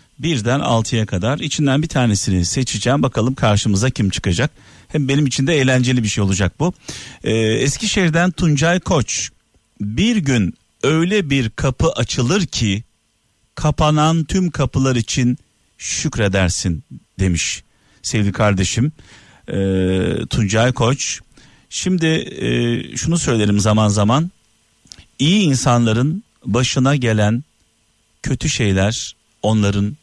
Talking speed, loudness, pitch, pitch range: 110 wpm, -17 LUFS, 120 Hz, 105-150 Hz